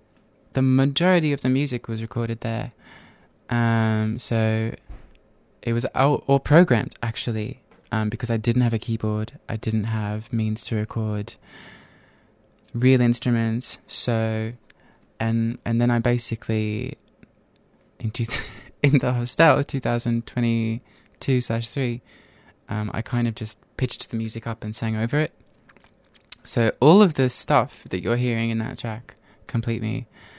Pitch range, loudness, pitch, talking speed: 110-125 Hz, -23 LUFS, 115 Hz, 140 wpm